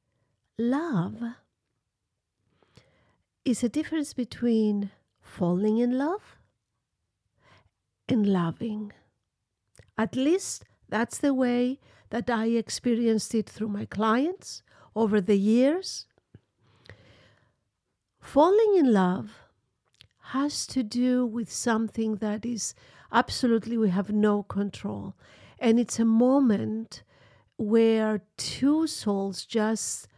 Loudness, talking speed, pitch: -26 LUFS, 95 wpm, 220 Hz